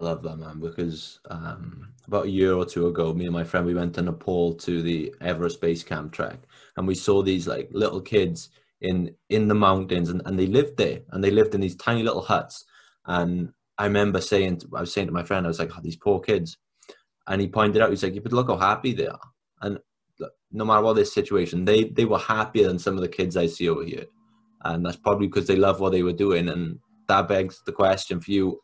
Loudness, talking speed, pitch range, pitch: -24 LUFS, 245 wpm, 85-100 Hz, 95 Hz